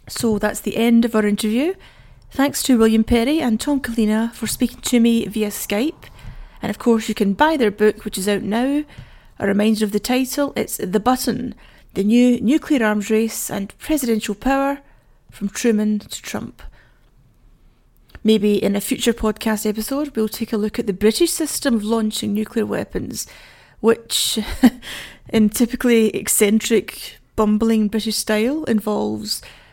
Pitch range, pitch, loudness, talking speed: 215-245 Hz, 225 Hz, -19 LUFS, 155 wpm